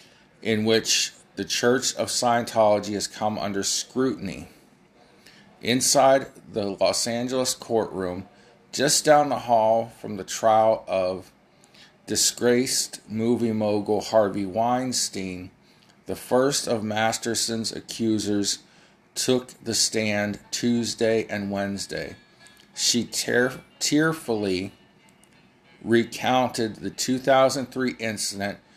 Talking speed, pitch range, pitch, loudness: 95 wpm, 105-120 Hz, 110 Hz, -23 LUFS